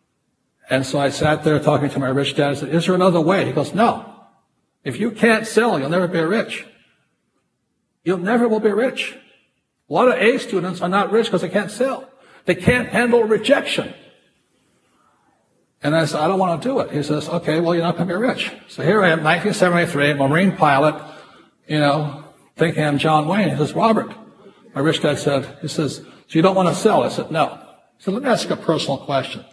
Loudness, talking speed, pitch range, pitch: -18 LUFS, 215 wpm, 150-210 Hz, 175 Hz